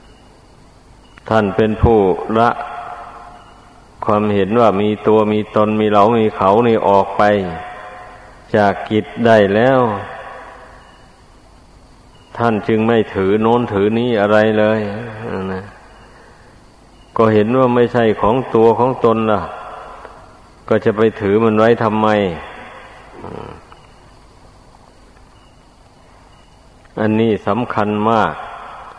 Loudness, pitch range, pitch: -15 LUFS, 105-115 Hz, 110 Hz